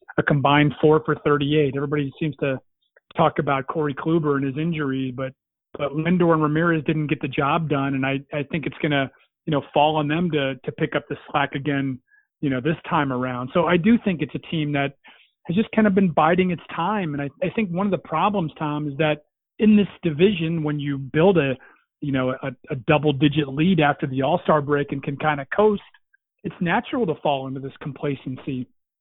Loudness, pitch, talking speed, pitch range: -22 LUFS, 150 Hz, 220 wpm, 140-165 Hz